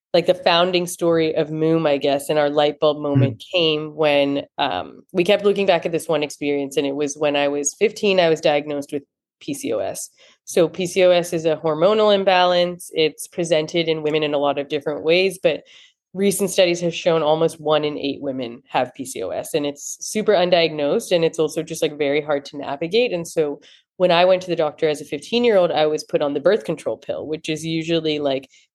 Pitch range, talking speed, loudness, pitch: 150-175 Hz, 215 wpm, -20 LUFS, 160 Hz